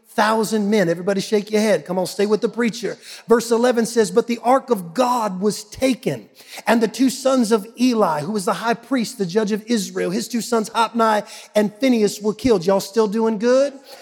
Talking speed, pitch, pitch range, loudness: 210 wpm, 220 Hz, 210-235 Hz, -19 LUFS